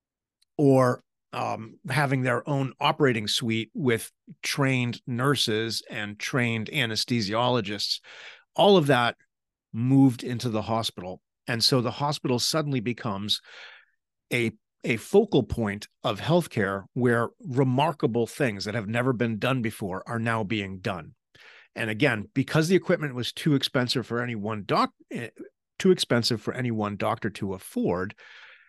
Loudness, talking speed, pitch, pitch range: -26 LUFS, 135 wpm, 120 Hz, 110-140 Hz